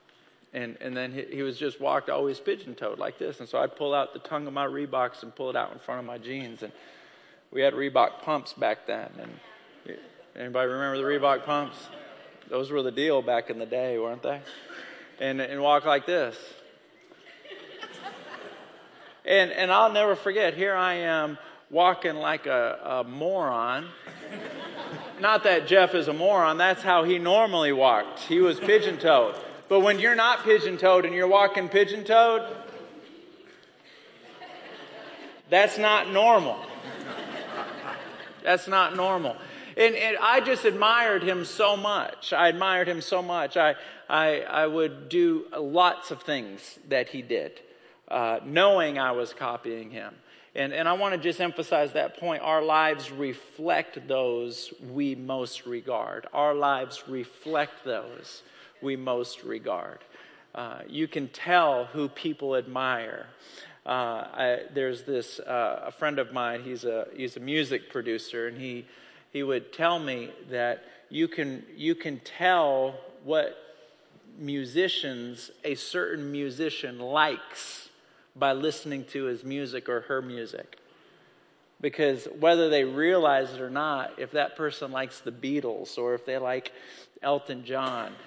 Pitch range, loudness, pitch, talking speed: 130-185 Hz, -26 LUFS, 150 Hz, 150 wpm